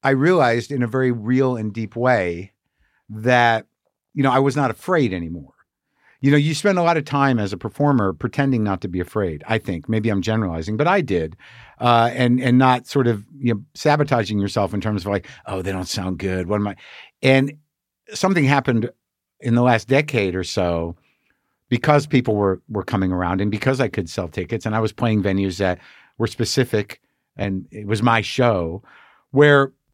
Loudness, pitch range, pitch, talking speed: -20 LUFS, 100-130 Hz, 115 Hz, 195 wpm